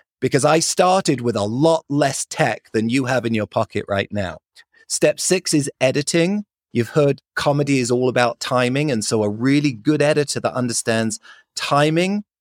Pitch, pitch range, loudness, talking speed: 140 Hz, 120-155 Hz, -19 LUFS, 175 wpm